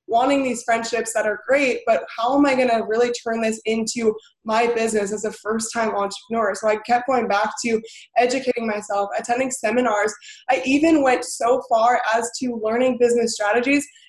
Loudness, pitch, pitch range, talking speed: -21 LUFS, 230 Hz, 215-250 Hz, 180 wpm